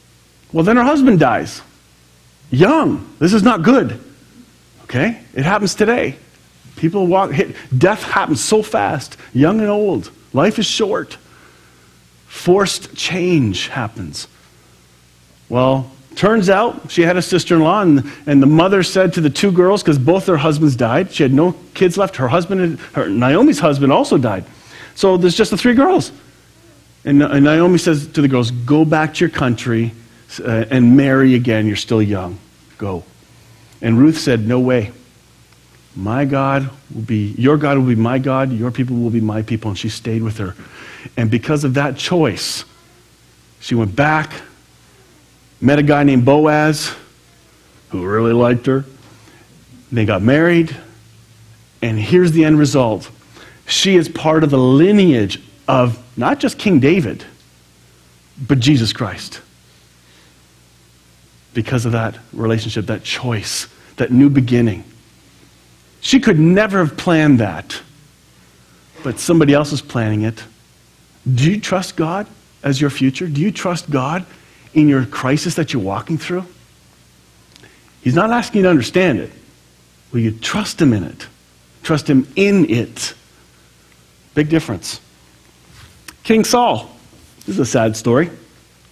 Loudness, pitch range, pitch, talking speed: -15 LUFS, 105-160 Hz, 130 Hz, 150 wpm